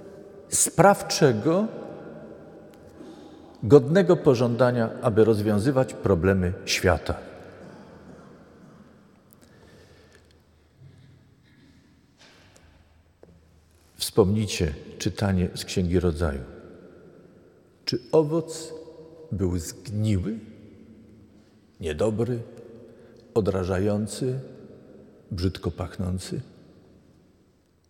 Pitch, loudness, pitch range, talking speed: 105 Hz, -24 LUFS, 90-120 Hz, 45 wpm